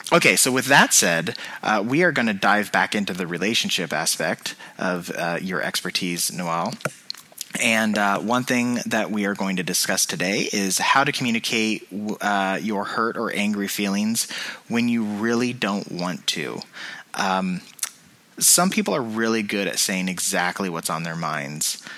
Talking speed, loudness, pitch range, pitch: 165 wpm, -21 LUFS, 95-115 Hz, 105 Hz